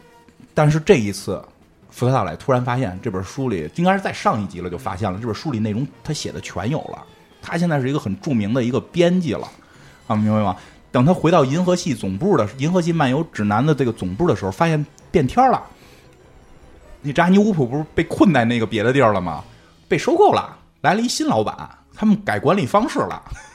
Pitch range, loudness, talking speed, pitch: 100-160 Hz, -19 LUFS, 320 characters per minute, 130 Hz